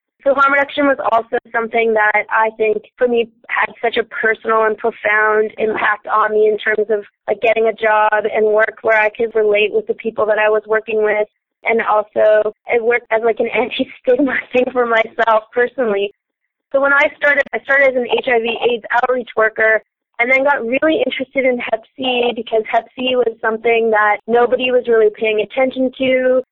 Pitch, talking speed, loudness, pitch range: 230 Hz, 190 wpm, -15 LUFS, 215-255 Hz